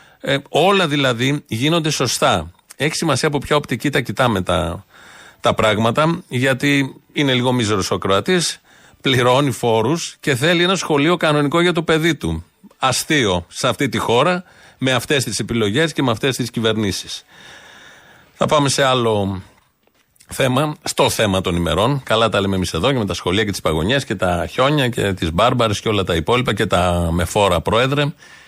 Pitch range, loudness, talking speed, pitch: 100-150 Hz, -17 LUFS, 175 wpm, 130 Hz